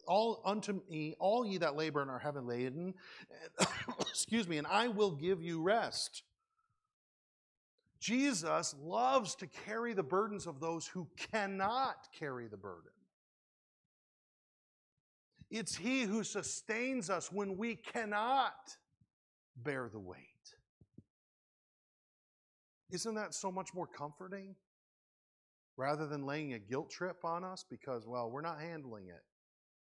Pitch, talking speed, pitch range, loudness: 180 Hz, 125 wpm, 150-210 Hz, -38 LUFS